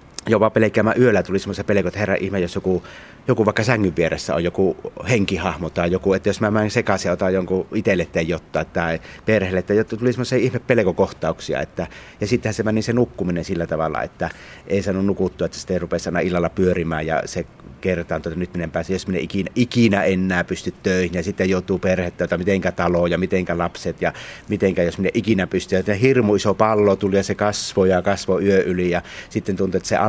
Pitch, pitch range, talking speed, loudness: 95 Hz, 90-105 Hz, 215 wpm, -20 LUFS